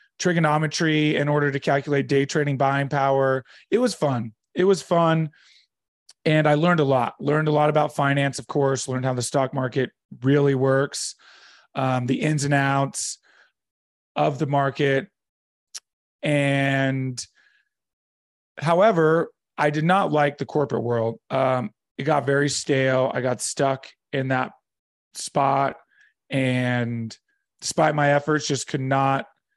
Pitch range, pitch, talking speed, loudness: 130-150 Hz, 140 Hz, 140 wpm, -22 LUFS